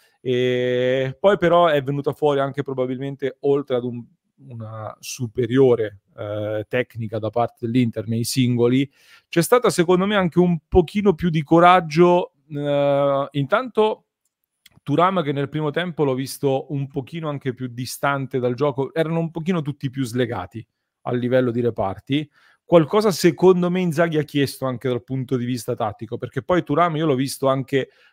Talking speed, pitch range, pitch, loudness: 160 wpm, 125-165 Hz, 140 Hz, -21 LUFS